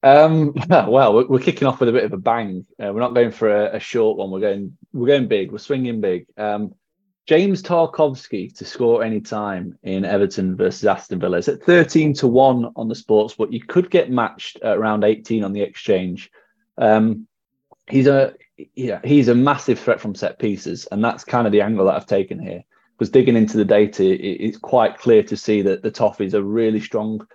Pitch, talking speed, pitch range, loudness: 120 Hz, 220 wpm, 105-145 Hz, -18 LUFS